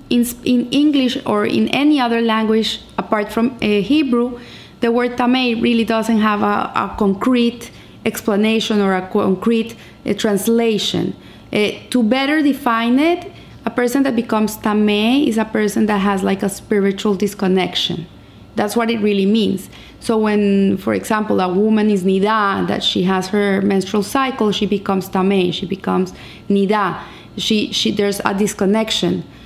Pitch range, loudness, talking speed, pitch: 200-235 Hz, -17 LUFS, 155 wpm, 215 Hz